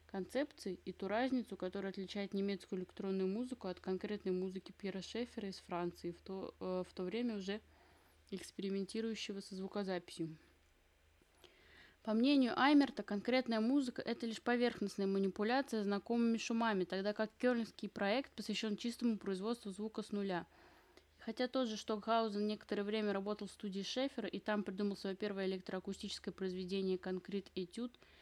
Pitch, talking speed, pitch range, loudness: 205 Hz, 140 wpm, 190-225 Hz, -40 LUFS